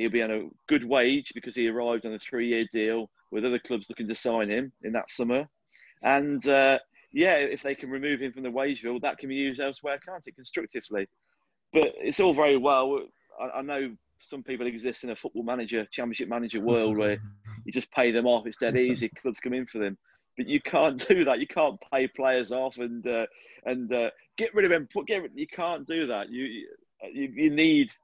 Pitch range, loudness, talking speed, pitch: 115-145 Hz, -28 LUFS, 215 wpm, 130 Hz